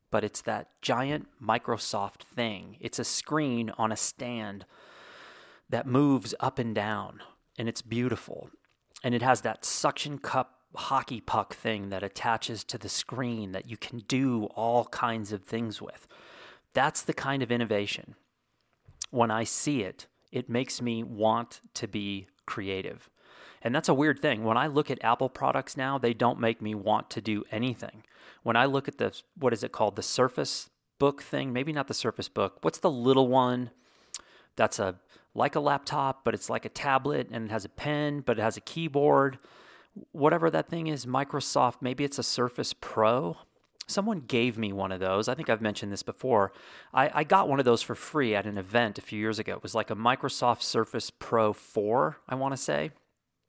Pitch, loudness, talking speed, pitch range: 120 Hz, -29 LUFS, 190 wpm, 110-135 Hz